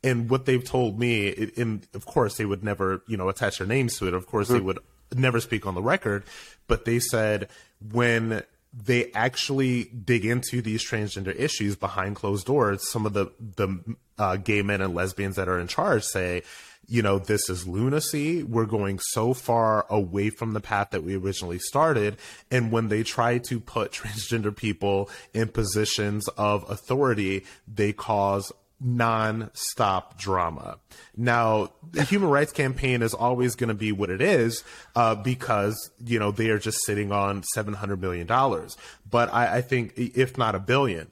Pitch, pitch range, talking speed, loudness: 110 Hz, 100-120 Hz, 175 wpm, -26 LUFS